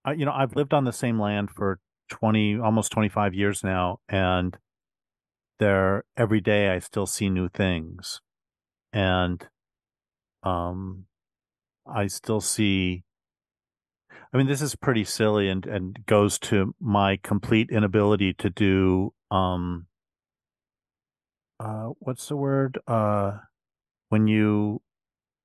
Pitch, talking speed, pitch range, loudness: 105 Hz, 120 wpm, 95-110 Hz, -25 LUFS